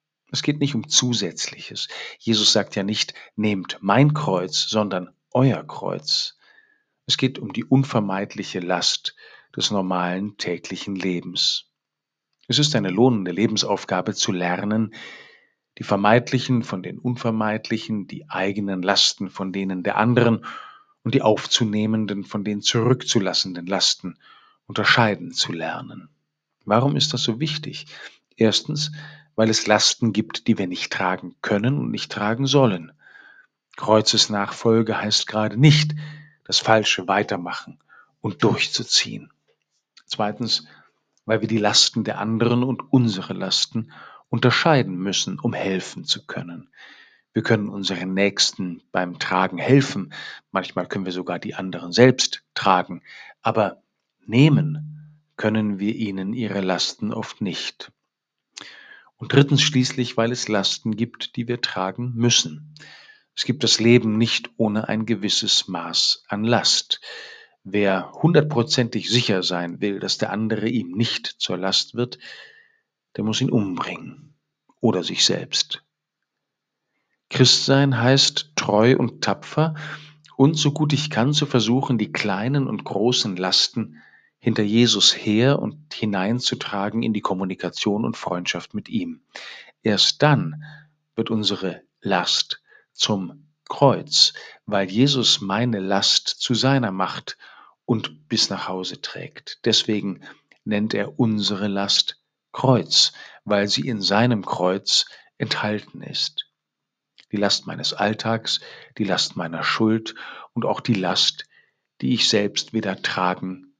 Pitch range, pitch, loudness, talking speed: 100-130 Hz, 110 Hz, -21 LUFS, 130 wpm